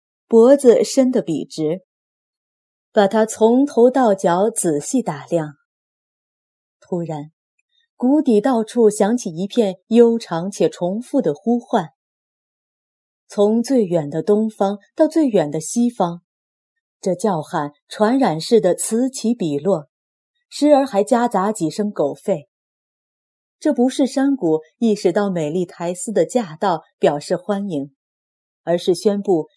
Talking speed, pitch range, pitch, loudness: 180 characters per minute, 175-240 Hz, 210 Hz, -18 LUFS